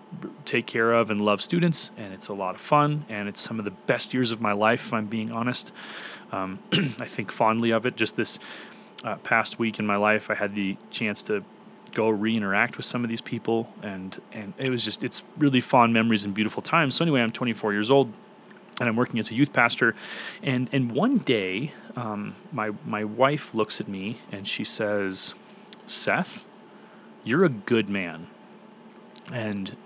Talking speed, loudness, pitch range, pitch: 195 wpm, -25 LUFS, 105-125 Hz, 115 Hz